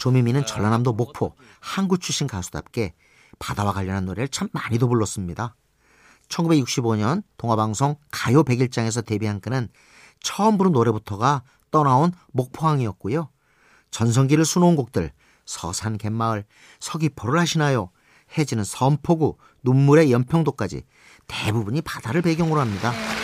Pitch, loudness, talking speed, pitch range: 125 Hz, -22 LUFS, 310 characters per minute, 110-155 Hz